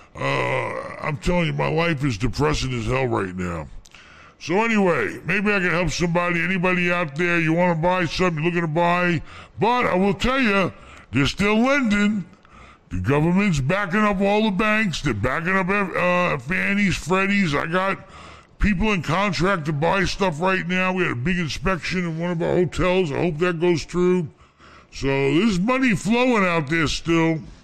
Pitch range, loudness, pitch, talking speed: 155-195 Hz, -21 LUFS, 175 Hz, 180 wpm